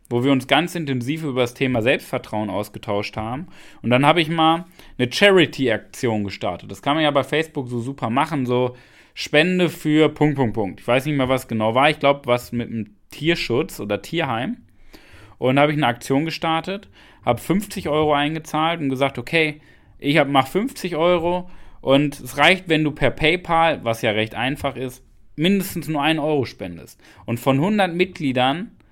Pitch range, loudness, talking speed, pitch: 125-160 Hz, -20 LUFS, 180 wpm, 140 Hz